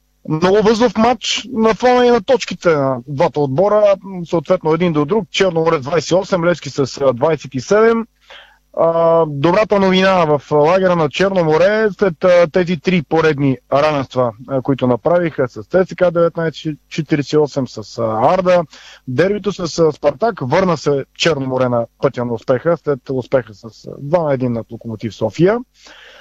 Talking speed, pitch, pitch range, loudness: 135 wpm, 165 Hz, 135-185 Hz, -15 LUFS